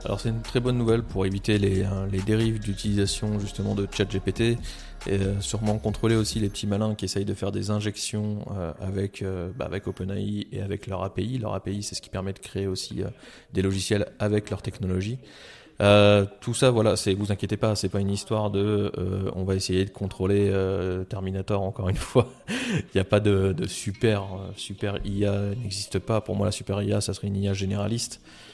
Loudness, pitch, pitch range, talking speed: -26 LUFS, 100 Hz, 95-105 Hz, 210 wpm